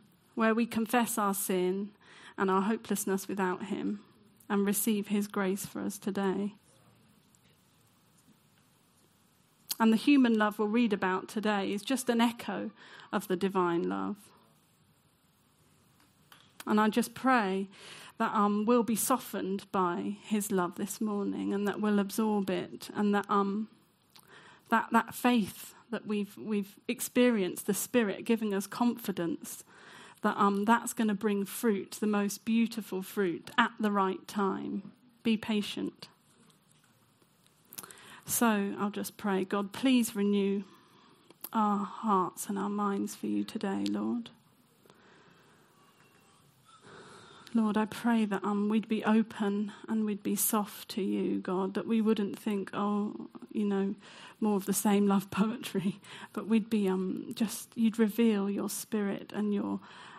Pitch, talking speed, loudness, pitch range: 205 Hz, 150 wpm, -31 LUFS, 195-225 Hz